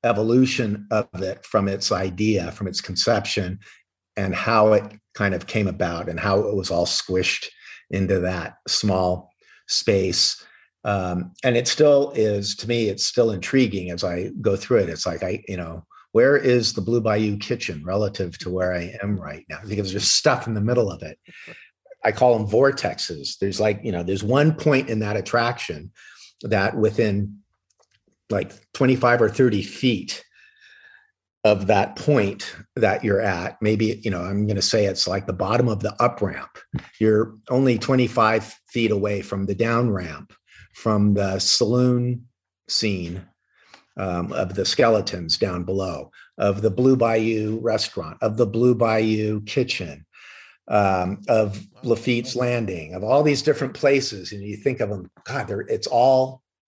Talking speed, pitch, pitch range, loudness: 165 wpm, 105 Hz, 95-120 Hz, -22 LUFS